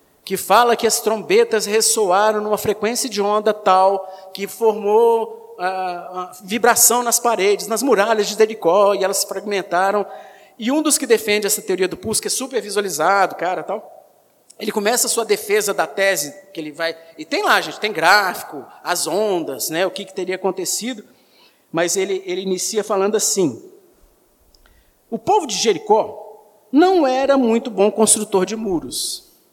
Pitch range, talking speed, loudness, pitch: 190-230 Hz, 165 wpm, -18 LUFS, 210 Hz